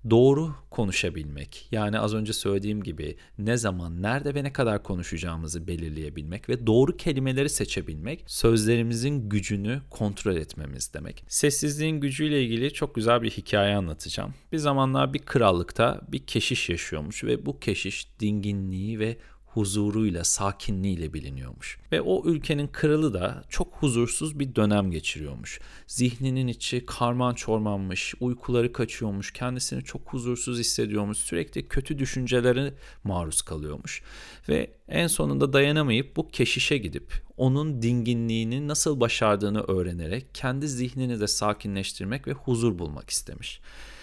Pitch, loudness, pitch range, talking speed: 115 Hz, -27 LUFS, 100-130 Hz, 125 wpm